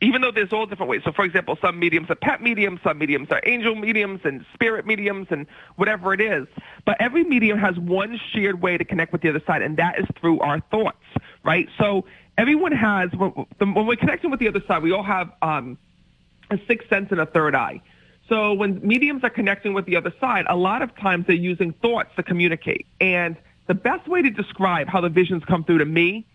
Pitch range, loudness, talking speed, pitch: 175-220 Hz, -21 LUFS, 225 wpm, 195 Hz